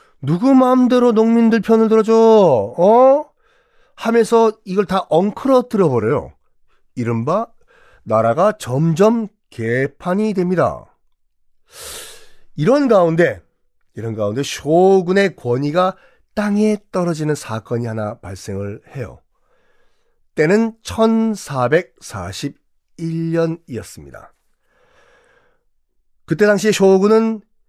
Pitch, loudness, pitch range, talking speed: 190 Hz, -16 LUFS, 140-225 Hz, 195 characters per minute